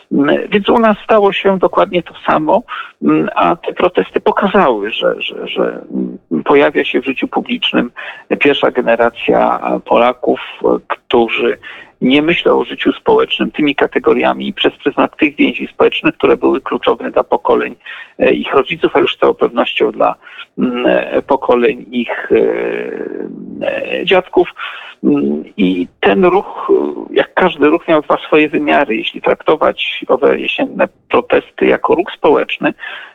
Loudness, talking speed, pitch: -13 LUFS, 130 wpm, 265 Hz